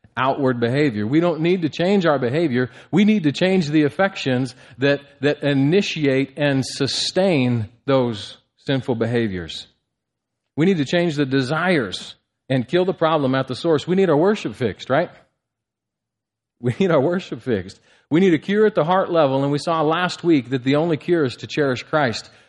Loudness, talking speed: -20 LUFS, 180 wpm